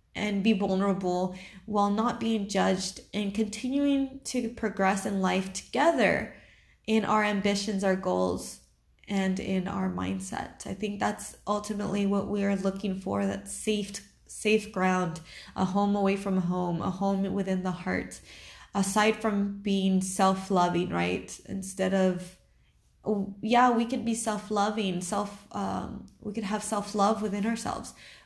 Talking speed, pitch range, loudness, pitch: 140 wpm, 185-210 Hz, -29 LUFS, 200 Hz